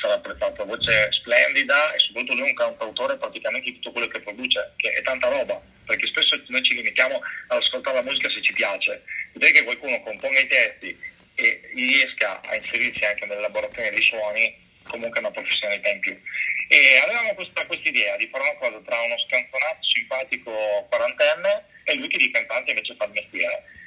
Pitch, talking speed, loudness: 295 Hz, 185 wpm, -21 LUFS